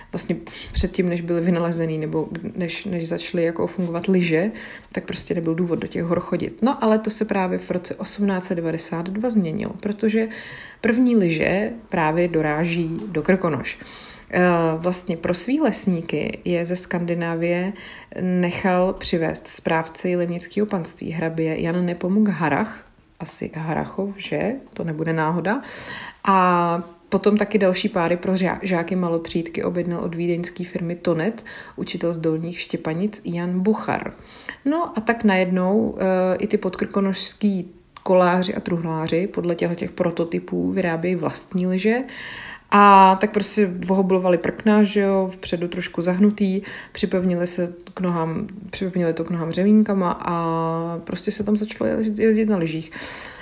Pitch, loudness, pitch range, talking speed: 180 Hz, -22 LUFS, 170-205 Hz, 140 wpm